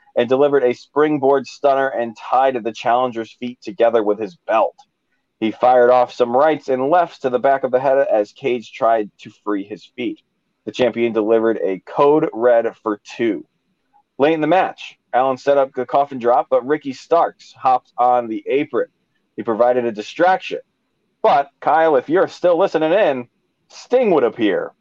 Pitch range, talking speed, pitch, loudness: 115-155 Hz, 175 wpm, 130 Hz, -17 LUFS